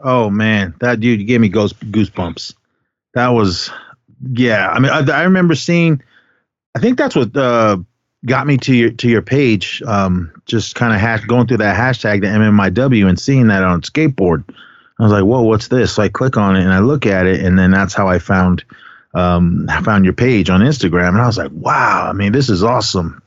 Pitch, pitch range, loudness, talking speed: 110 Hz, 95-125 Hz, -13 LUFS, 210 wpm